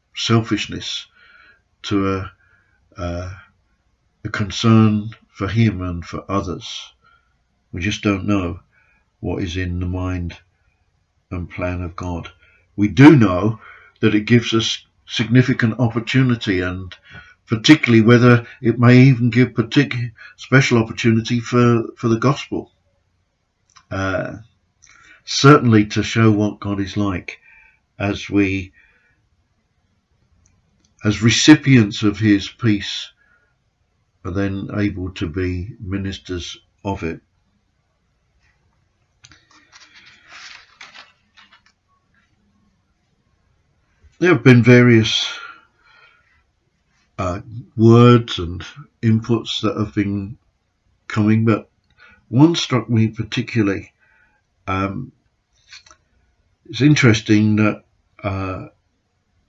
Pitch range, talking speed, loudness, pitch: 95-115 Hz, 95 wpm, -17 LUFS, 105 Hz